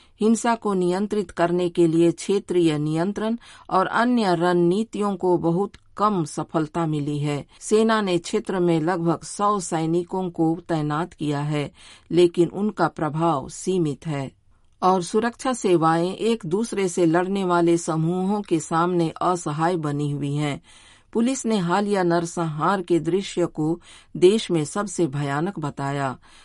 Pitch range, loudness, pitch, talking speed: 160-195 Hz, -23 LUFS, 175 Hz, 135 wpm